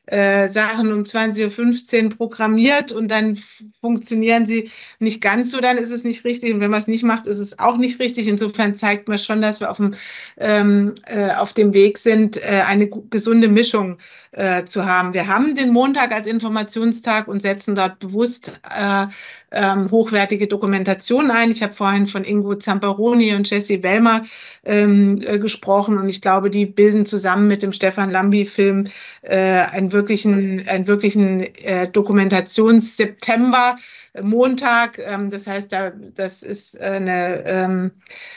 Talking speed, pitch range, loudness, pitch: 150 wpm, 200-225 Hz, -17 LUFS, 210 Hz